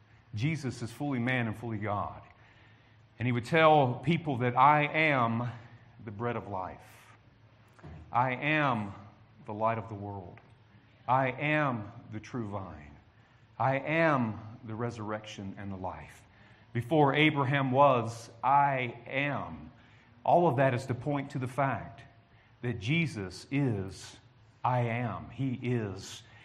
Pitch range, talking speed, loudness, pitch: 110-135 Hz, 135 wpm, -30 LUFS, 120 Hz